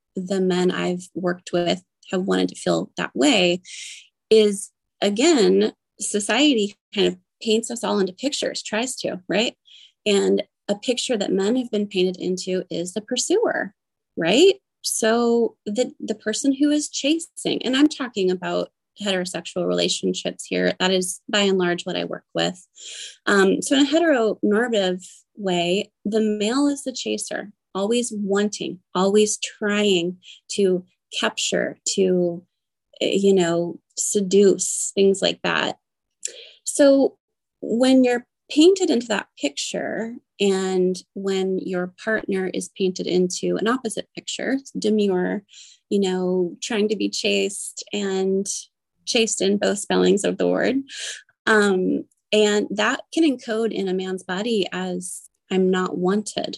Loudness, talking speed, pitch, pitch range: -22 LUFS, 135 wpm, 200 Hz, 185-225 Hz